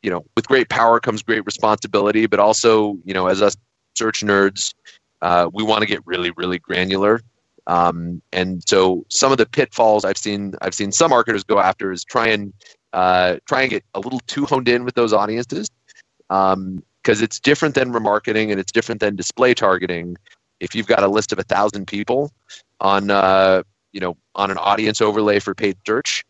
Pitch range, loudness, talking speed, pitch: 95-110 Hz, -18 LUFS, 190 wpm, 100 Hz